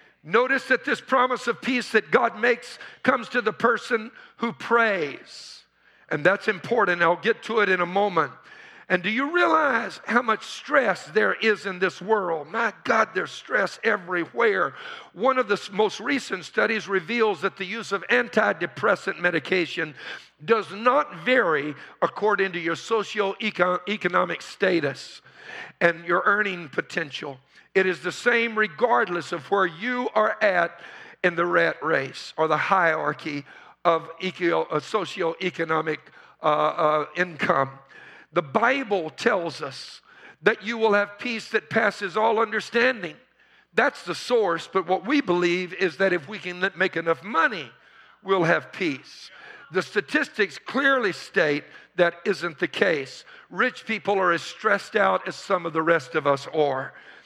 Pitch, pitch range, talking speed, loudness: 200 Hz, 175-230 Hz, 150 wpm, -24 LUFS